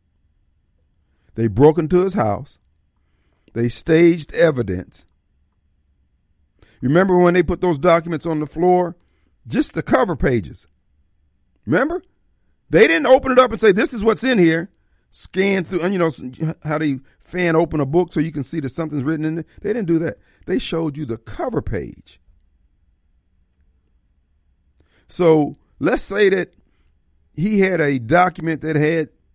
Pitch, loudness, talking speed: 145 Hz, -18 LUFS, 150 wpm